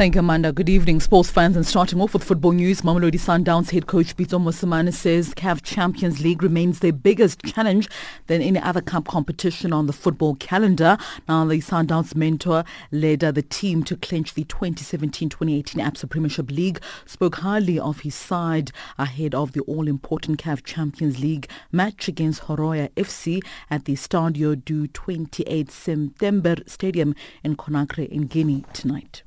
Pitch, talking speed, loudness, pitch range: 165 Hz, 160 wpm, -22 LUFS, 150-180 Hz